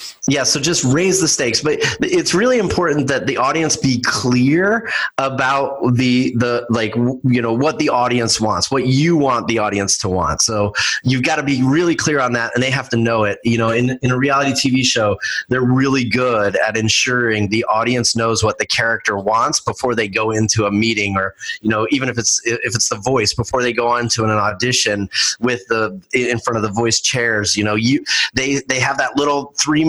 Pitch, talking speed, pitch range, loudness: 125 Hz, 215 wpm, 110-135 Hz, -16 LUFS